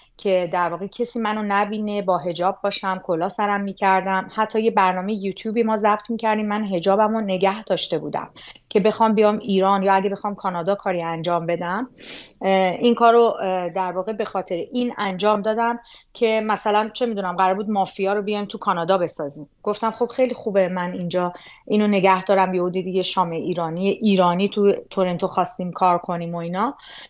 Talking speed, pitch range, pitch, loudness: 175 wpm, 185-215 Hz, 195 Hz, -21 LUFS